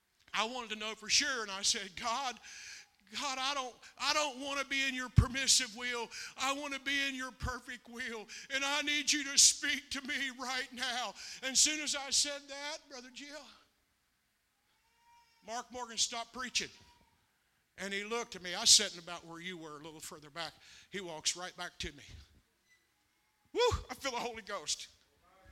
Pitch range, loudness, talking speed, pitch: 215-280 Hz, -33 LUFS, 190 wpm, 255 Hz